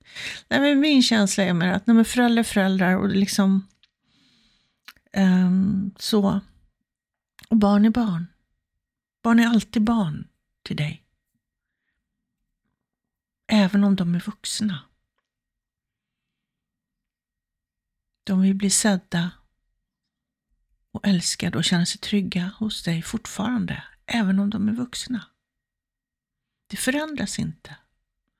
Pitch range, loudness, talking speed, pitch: 190-225 Hz, -22 LUFS, 105 wpm, 200 Hz